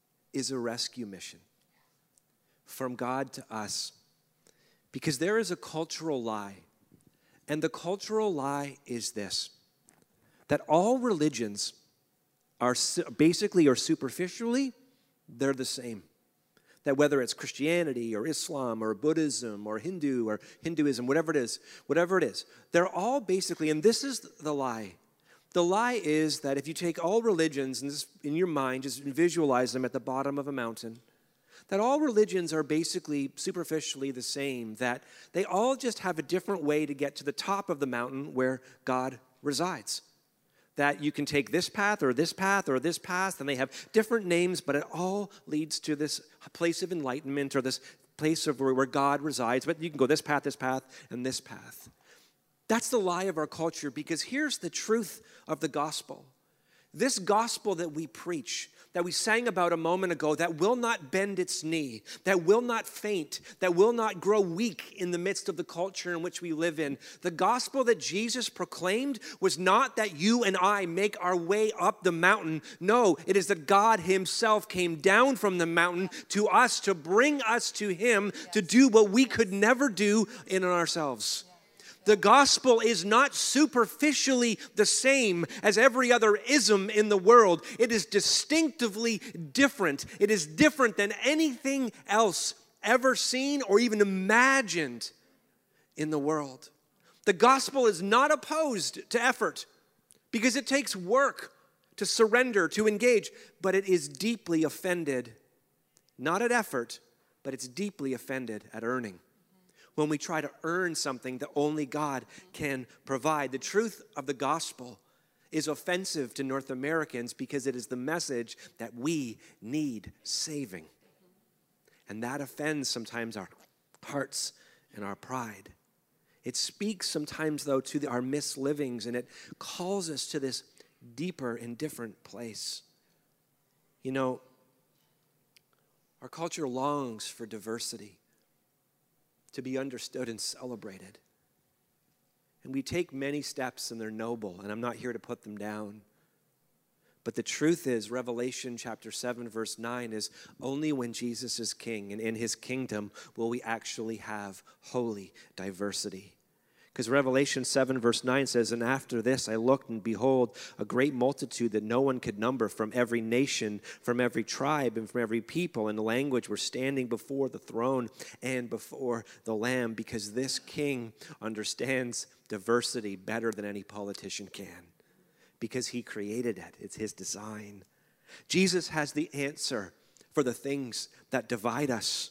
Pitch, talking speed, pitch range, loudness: 150 Hz, 160 wpm, 125-195 Hz, -29 LUFS